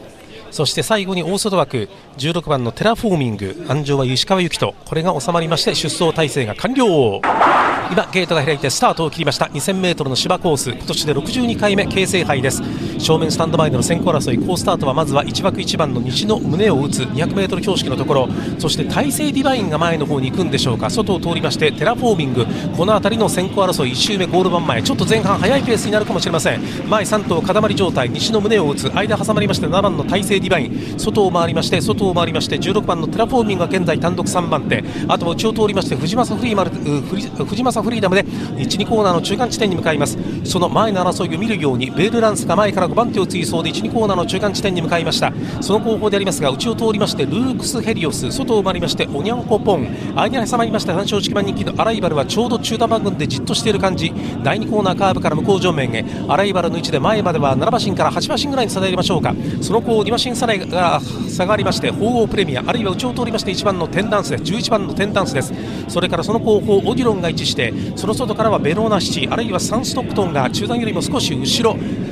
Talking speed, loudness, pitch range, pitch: 450 characters per minute, -17 LUFS, 155-215 Hz, 185 Hz